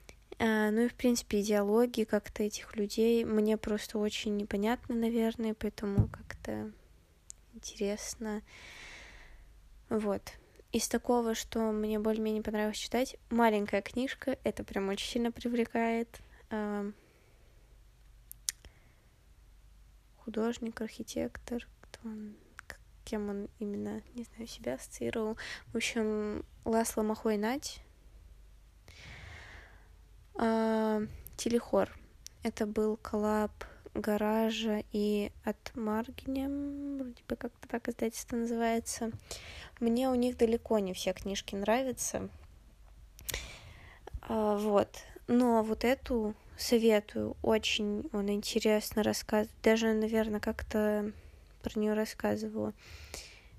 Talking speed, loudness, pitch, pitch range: 95 wpm, -33 LUFS, 220 Hz, 210-230 Hz